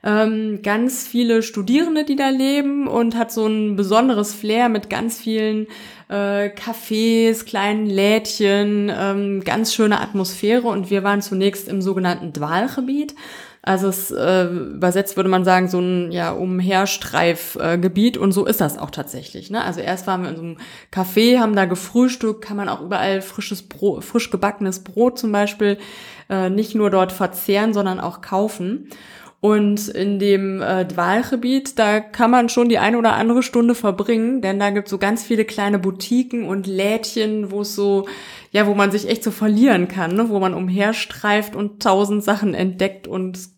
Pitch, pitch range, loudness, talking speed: 205 Hz, 195-225 Hz, -19 LUFS, 170 wpm